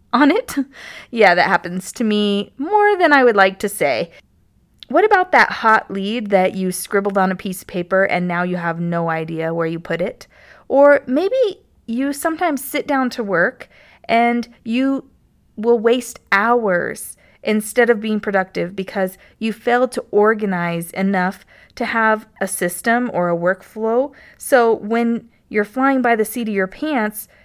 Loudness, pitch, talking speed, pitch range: -18 LUFS, 220 Hz, 170 wpm, 190-250 Hz